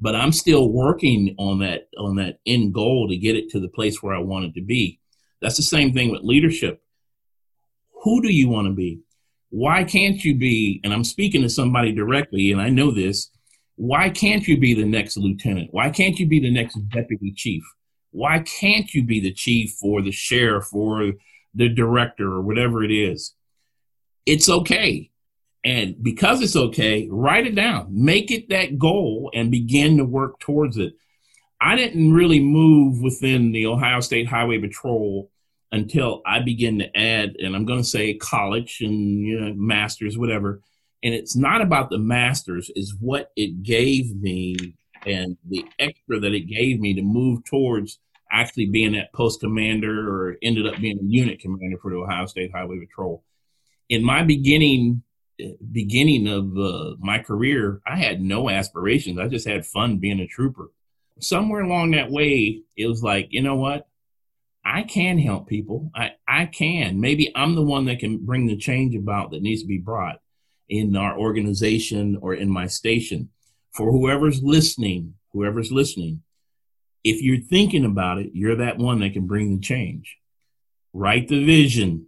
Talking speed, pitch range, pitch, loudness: 175 wpm, 100-135 Hz, 115 Hz, -20 LUFS